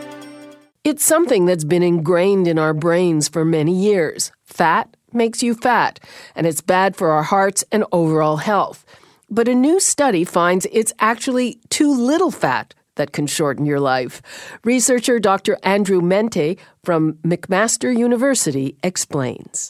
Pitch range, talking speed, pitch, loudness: 165-245 Hz, 145 wpm, 195 Hz, -17 LUFS